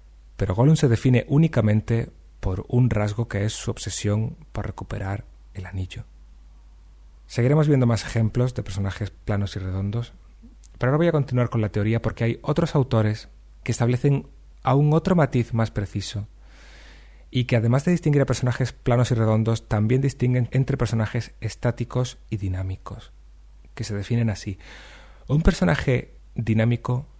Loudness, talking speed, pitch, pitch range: -23 LUFS, 150 wpm, 115 Hz, 100-125 Hz